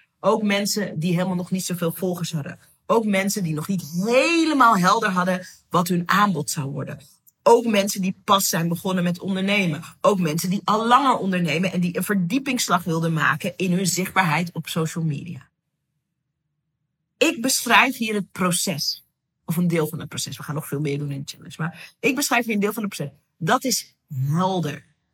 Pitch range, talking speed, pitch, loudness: 155-200 Hz, 190 wpm, 180 Hz, -22 LUFS